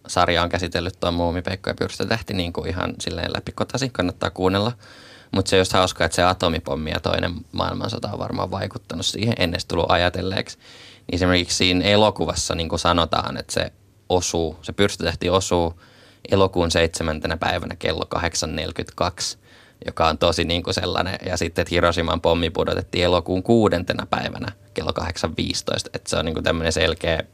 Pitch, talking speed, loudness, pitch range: 90 Hz, 160 wpm, -22 LUFS, 85-95 Hz